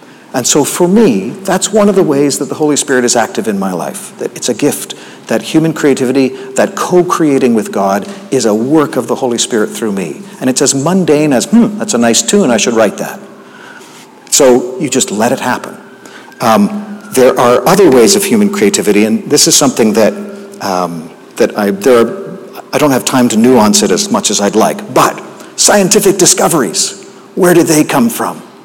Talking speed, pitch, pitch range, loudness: 205 wpm, 150 Hz, 125-200 Hz, -10 LUFS